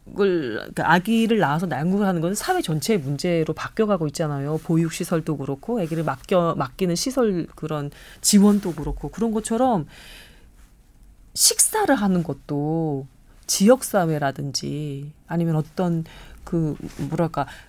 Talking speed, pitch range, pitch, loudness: 285 characters per minute, 150-200 Hz, 165 Hz, -22 LUFS